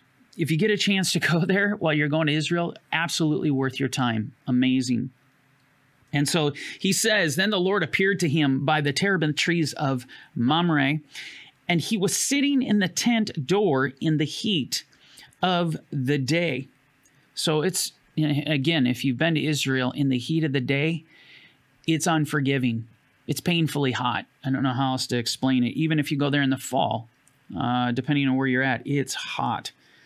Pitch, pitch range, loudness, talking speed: 150 Hz, 135-165 Hz, -24 LUFS, 180 wpm